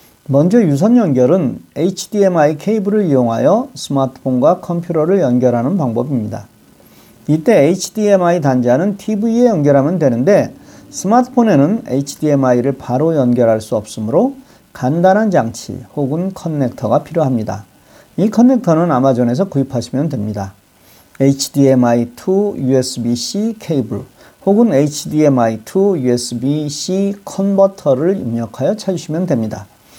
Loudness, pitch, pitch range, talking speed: -14 LUFS, 145 Hz, 125-195 Hz, 300 characters per minute